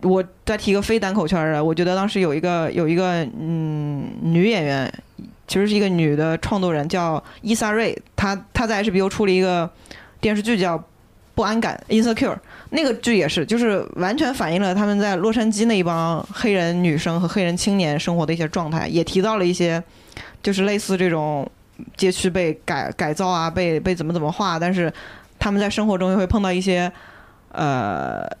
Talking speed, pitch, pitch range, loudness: 310 characters per minute, 185 Hz, 165-205 Hz, -21 LUFS